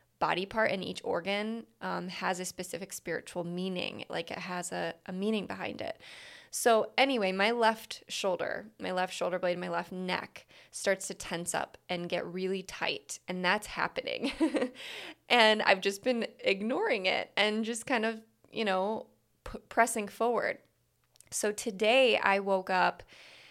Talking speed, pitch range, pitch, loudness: 160 wpm, 185-230 Hz, 205 Hz, -31 LUFS